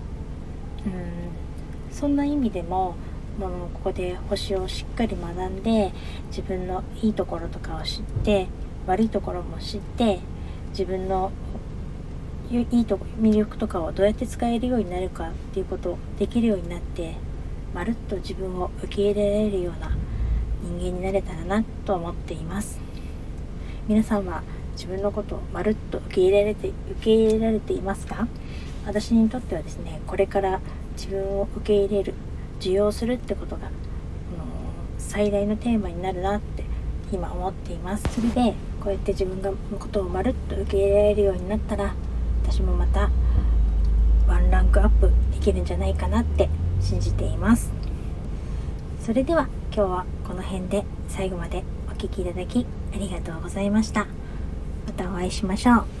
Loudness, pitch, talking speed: -26 LUFS, 185 Hz, 330 characters per minute